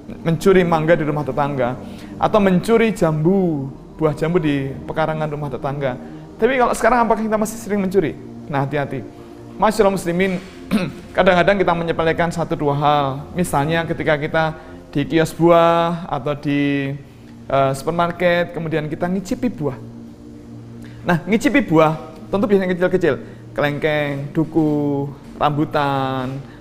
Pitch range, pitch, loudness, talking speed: 140-175 Hz, 155 Hz, -19 LUFS, 120 wpm